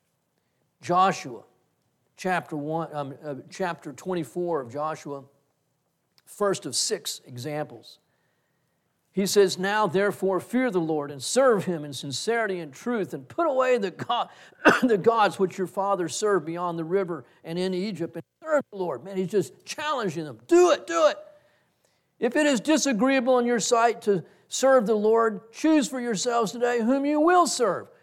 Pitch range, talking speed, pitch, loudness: 155-240 Hz, 165 wpm, 190 Hz, -25 LUFS